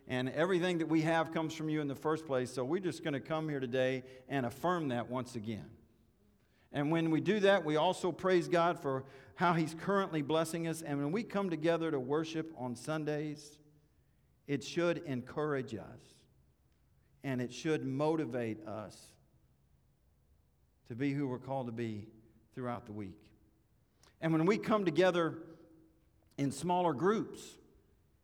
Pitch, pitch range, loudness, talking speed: 150 Hz, 125-165 Hz, -35 LUFS, 160 wpm